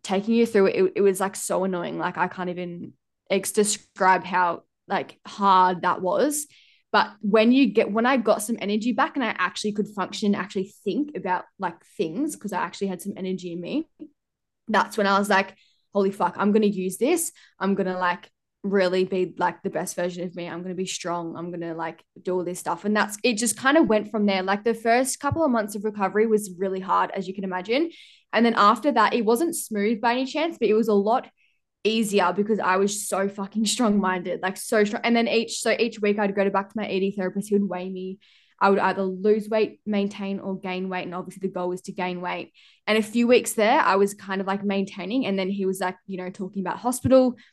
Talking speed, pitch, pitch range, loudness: 235 wpm, 200 Hz, 185-220 Hz, -24 LUFS